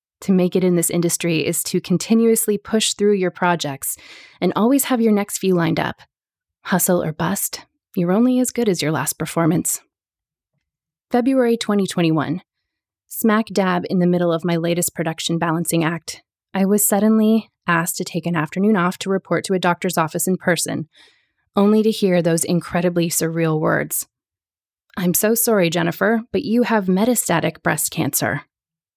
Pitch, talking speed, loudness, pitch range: 180 Hz, 165 wpm, -19 LUFS, 165-205 Hz